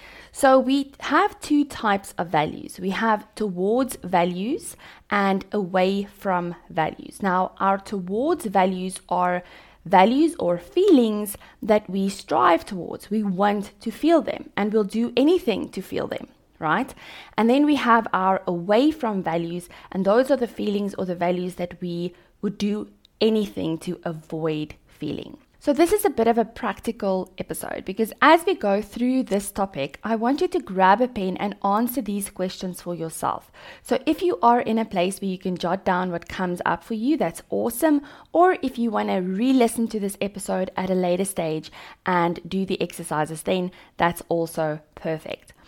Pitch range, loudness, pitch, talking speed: 180-235 Hz, -23 LUFS, 200 Hz, 175 wpm